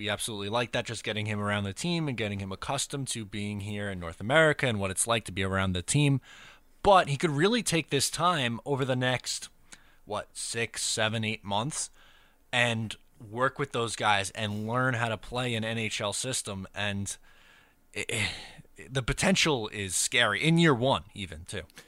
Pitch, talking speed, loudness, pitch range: 115 Hz, 190 wpm, -28 LUFS, 105-135 Hz